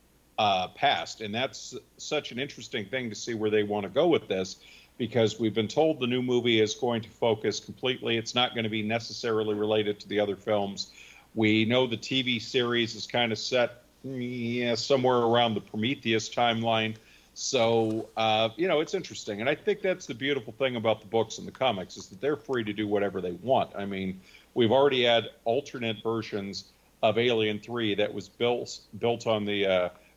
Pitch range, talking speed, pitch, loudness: 105-120 Hz, 200 wpm, 115 Hz, -28 LUFS